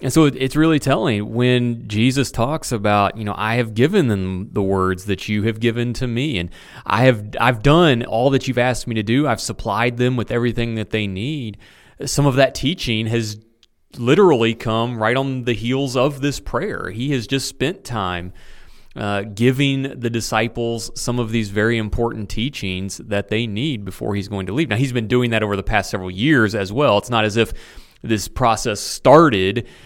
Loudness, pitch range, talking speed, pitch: -19 LUFS, 105-130 Hz, 200 wpm, 115 Hz